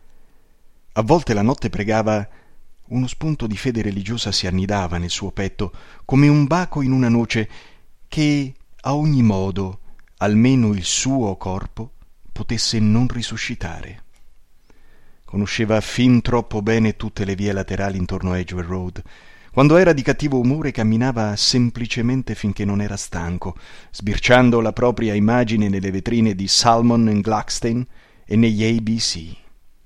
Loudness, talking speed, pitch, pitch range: -19 LUFS, 135 wpm, 110 Hz, 100-120 Hz